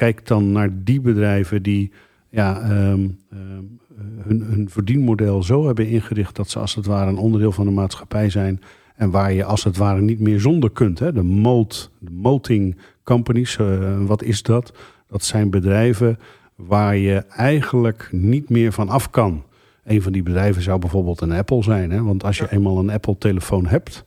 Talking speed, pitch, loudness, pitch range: 180 wpm, 105 Hz, -19 LUFS, 100-115 Hz